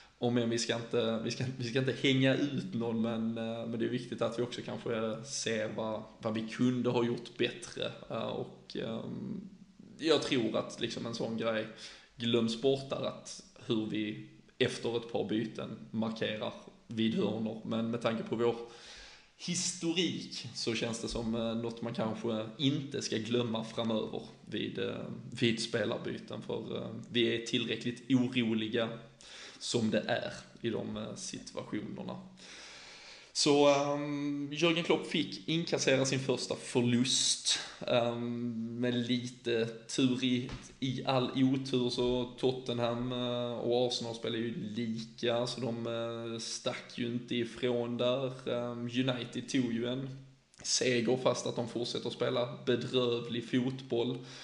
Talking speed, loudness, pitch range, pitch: 140 wpm, -34 LUFS, 115-130 Hz, 120 Hz